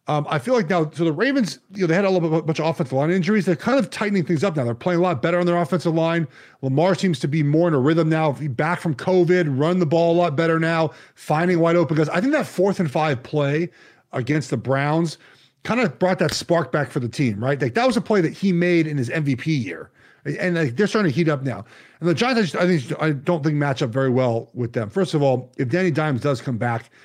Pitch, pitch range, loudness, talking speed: 165 Hz, 145-180 Hz, -21 LUFS, 270 wpm